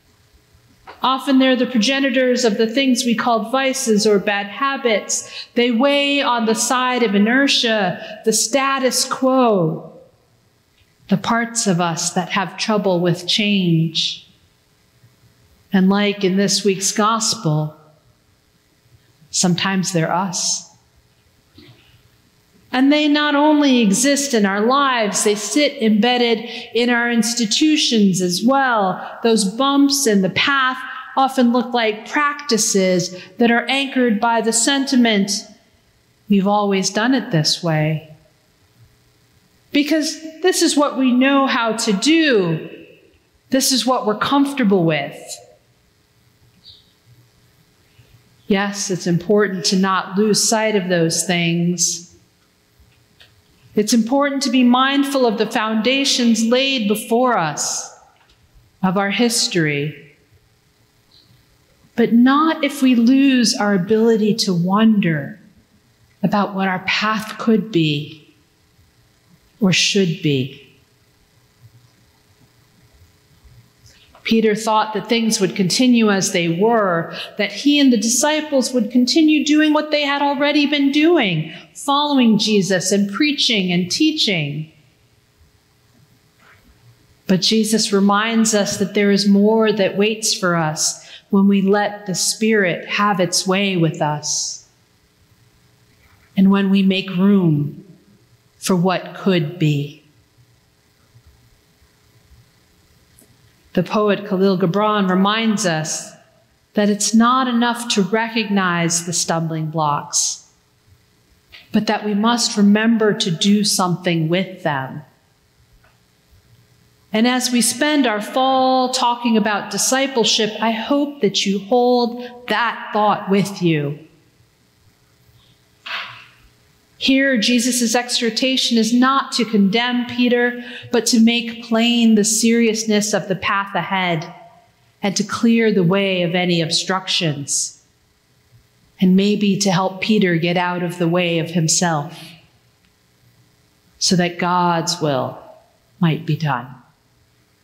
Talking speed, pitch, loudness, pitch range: 115 wpm, 205 Hz, -17 LUFS, 170-240 Hz